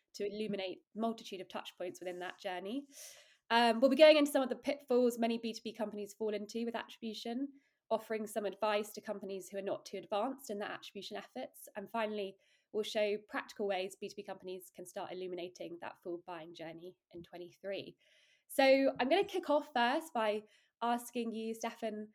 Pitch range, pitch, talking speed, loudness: 195-240 Hz, 215 Hz, 180 wpm, -36 LUFS